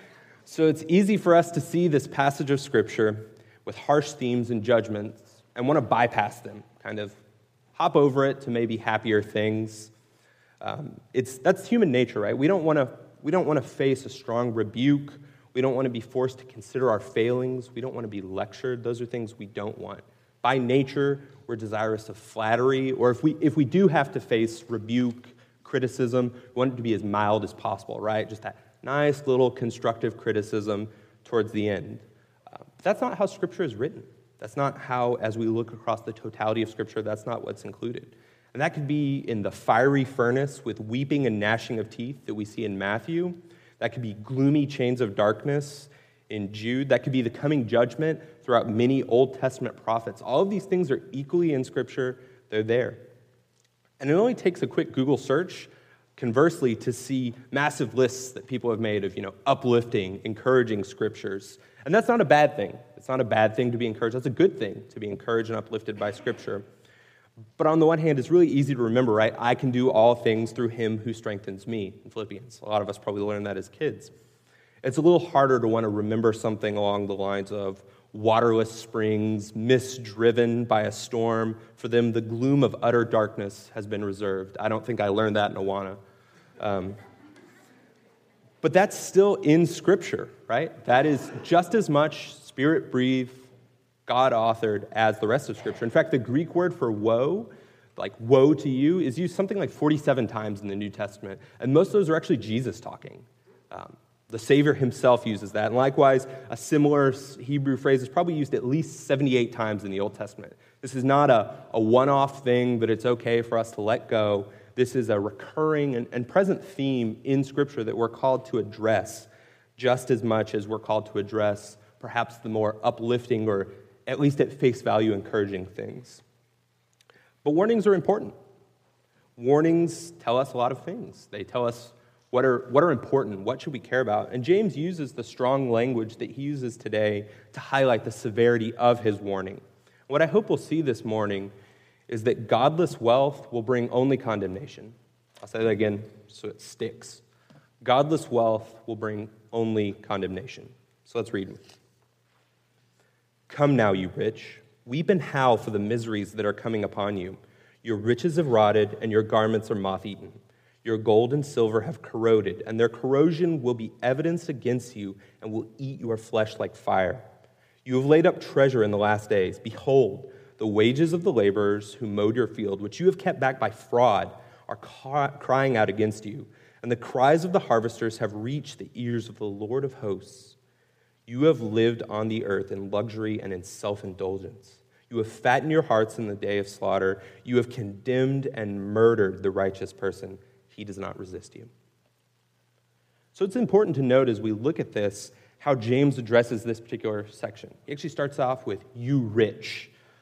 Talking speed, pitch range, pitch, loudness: 190 wpm, 110-135 Hz, 120 Hz, -25 LUFS